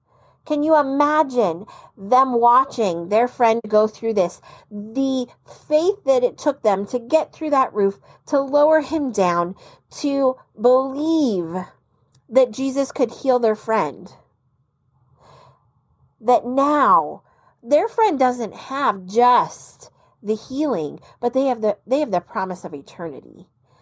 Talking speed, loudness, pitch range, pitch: 130 wpm, -20 LUFS, 205-275 Hz, 245 Hz